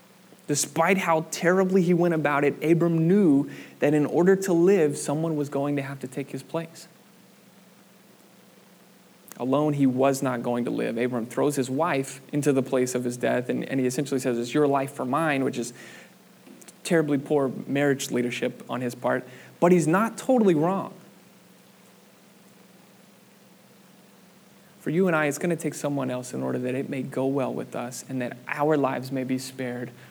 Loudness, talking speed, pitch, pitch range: -25 LUFS, 180 wpm, 145 Hz, 130-175 Hz